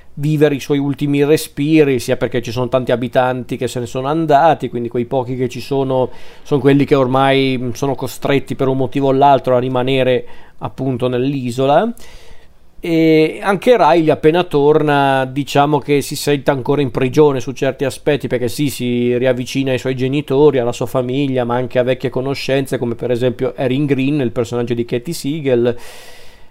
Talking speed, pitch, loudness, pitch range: 175 wpm, 135 Hz, -15 LUFS, 125-145 Hz